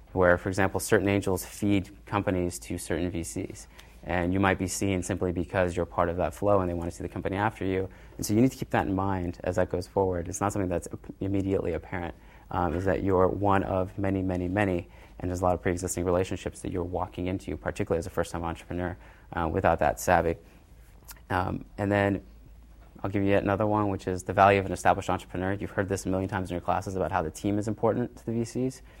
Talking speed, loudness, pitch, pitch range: 235 wpm, -28 LUFS, 95 Hz, 90-100 Hz